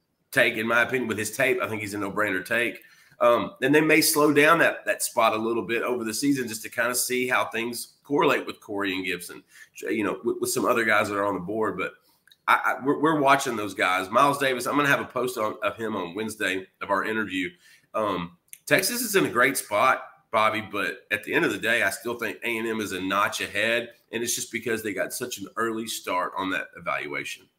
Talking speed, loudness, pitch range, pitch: 245 wpm, -25 LUFS, 100-125 Hz, 115 Hz